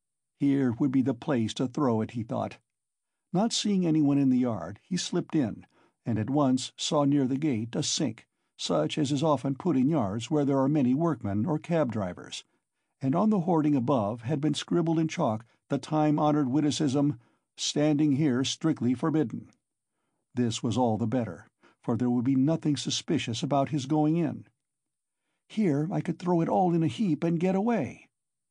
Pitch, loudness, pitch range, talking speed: 145 Hz, -28 LUFS, 125-155 Hz, 185 wpm